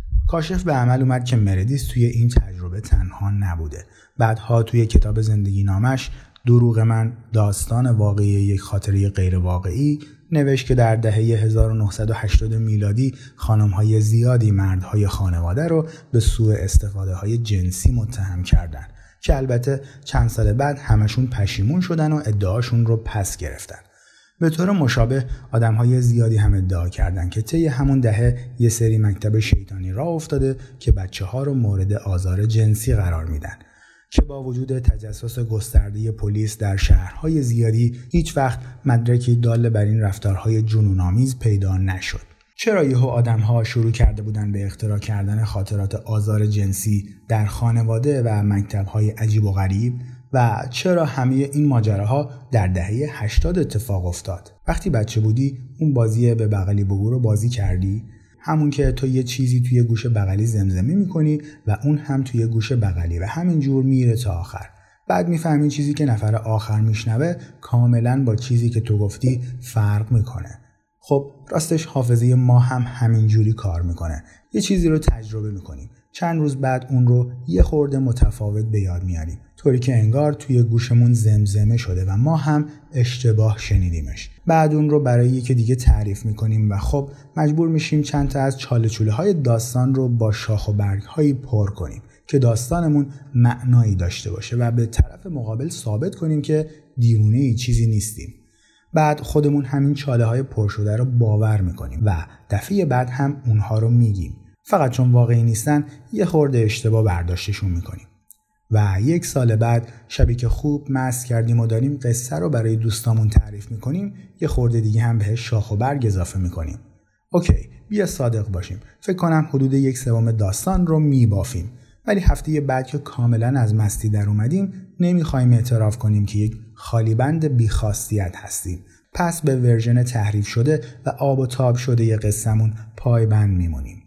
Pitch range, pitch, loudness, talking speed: 105-130 Hz, 115 Hz, -20 LUFS, 160 wpm